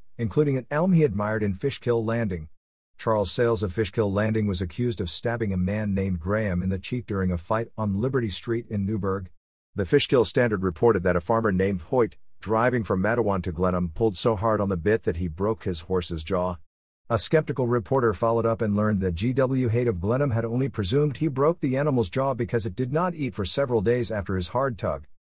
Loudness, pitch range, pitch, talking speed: -25 LUFS, 95-120 Hz, 110 Hz, 215 wpm